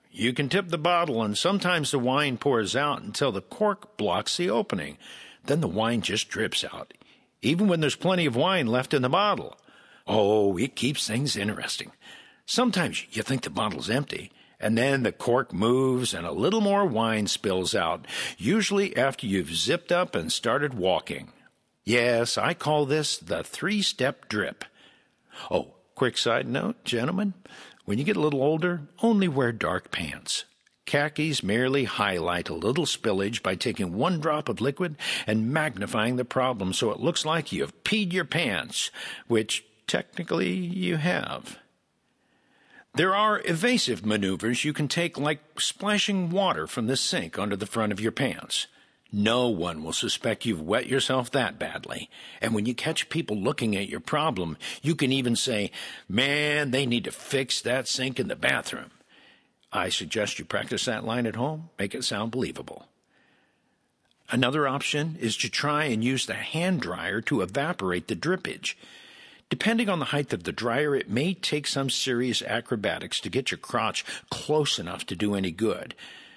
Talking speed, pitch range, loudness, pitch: 170 wpm, 115-170 Hz, -26 LUFS, 135 Hz